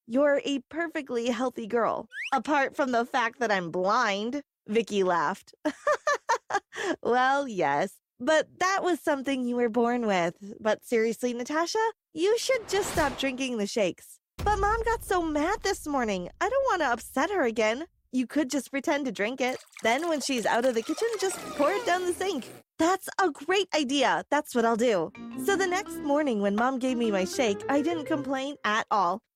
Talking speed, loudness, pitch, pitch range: 185 wpm, -27 LUFS, 275 Hz, 235-335 Hz